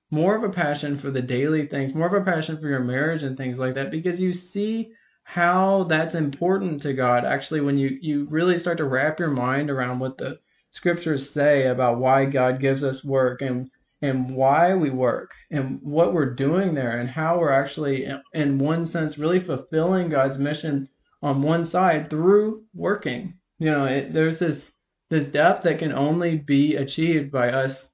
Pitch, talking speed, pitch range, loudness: 150 Hz, 190 wpm, 135-170 Hz, -23 LUFS